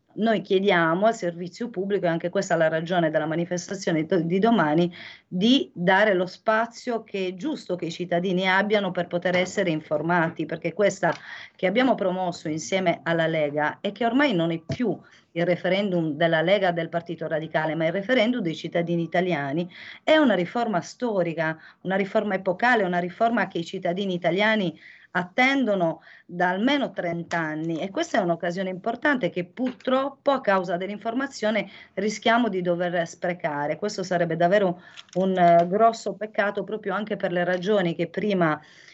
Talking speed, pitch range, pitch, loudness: 155 wpm, 170-210 Hz, 180 Hz, -24 LUFS